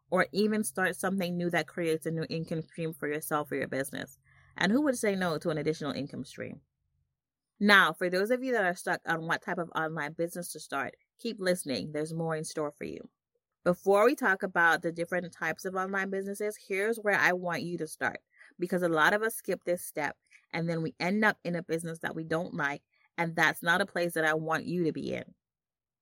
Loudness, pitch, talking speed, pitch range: -30 LUFS, 175 Hz, 230 wpm, 160-190 Hz